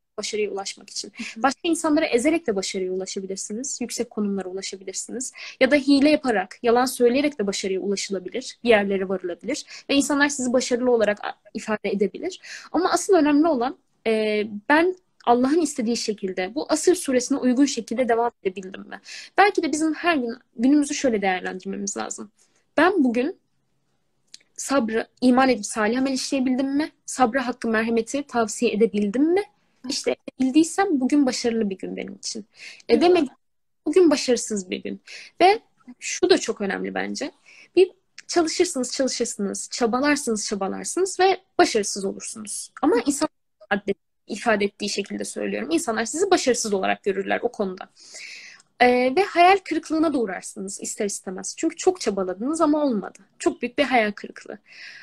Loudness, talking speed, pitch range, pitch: -23 LUFS, 140 wpm, 210-300 Hz, 245 Hz